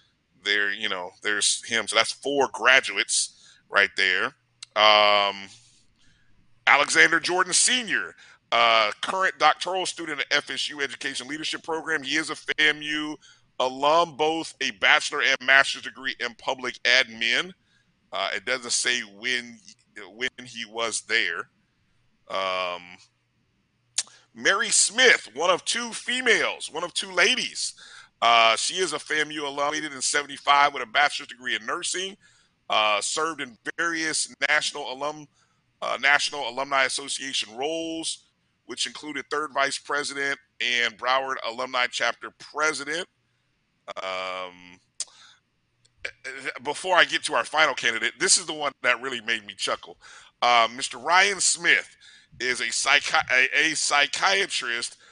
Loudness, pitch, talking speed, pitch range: -23 LUFS, 140 Hz, 130 wpm, 115-155 Hz